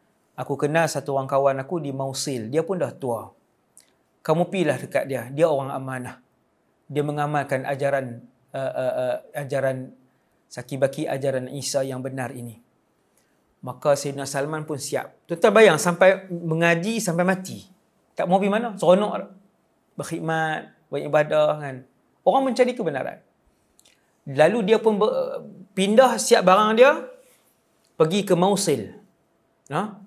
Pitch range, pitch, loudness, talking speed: 140-195 Hz, 155 Hz, -22 LUFS, 135 wpm